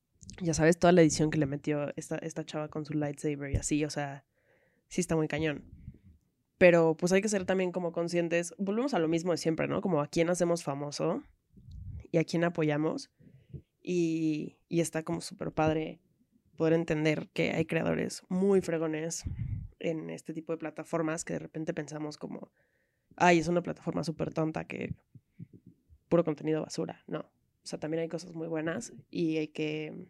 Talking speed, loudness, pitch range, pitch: 180 wpm, -31 LUFS, 155-170 Hz, 160 Hz